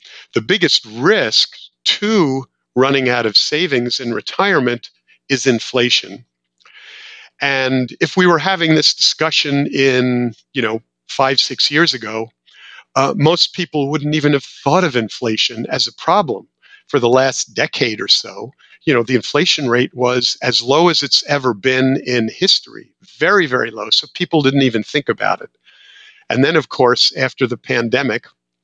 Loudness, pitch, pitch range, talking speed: -15 LUFS, 130 Hz, 120-150 Hz, 155 wpm